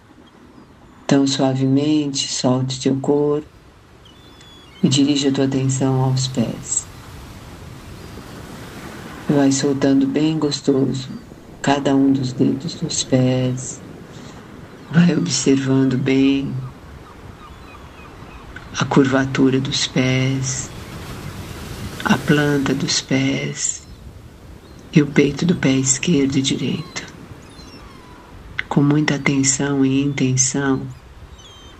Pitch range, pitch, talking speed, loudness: 130-140 Hz, 135 Hz, 85 wpm, -18 LUFS